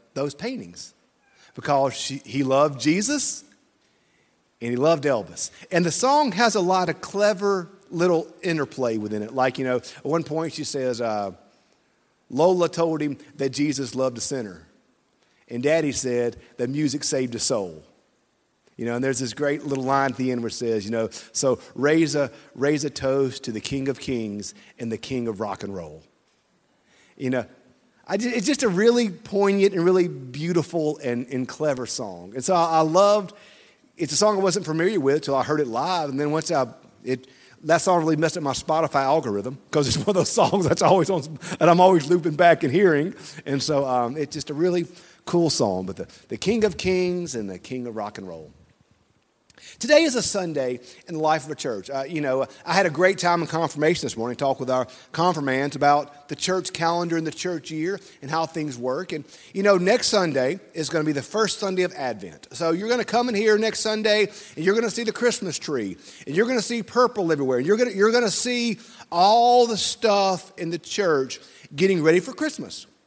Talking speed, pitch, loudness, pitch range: 210 wpm, 155 Hz, -23 LUFS, 130-185 Hz